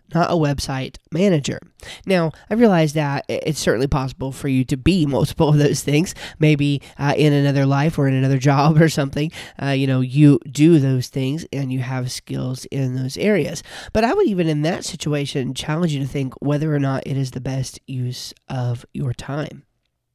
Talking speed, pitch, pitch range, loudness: 195 wpm, 140 Hz, 130-155 Hz, -19 LUFS